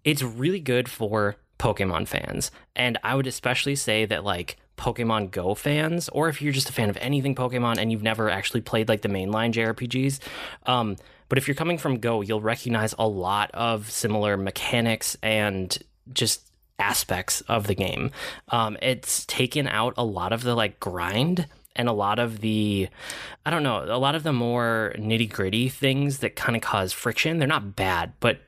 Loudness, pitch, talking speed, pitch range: -25 LUFS, 115 Hz, 190 wpm, 110-130 Hz